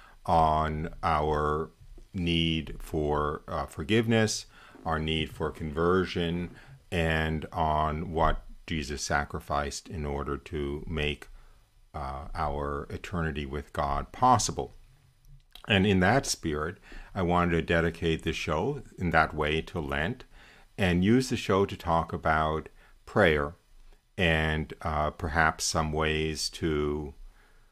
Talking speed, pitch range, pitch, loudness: 115 wpm, 75-95 Hz, 80 Hz, -29 LUFS